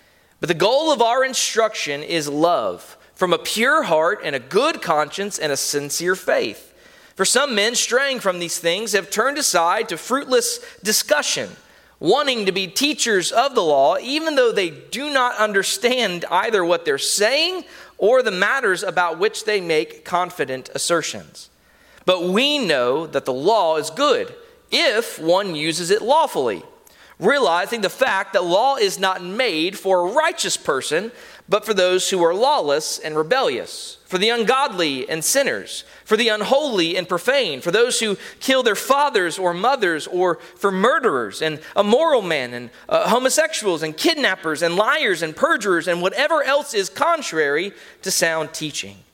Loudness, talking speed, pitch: -19 LUFS, 160 wpm, 215 Hz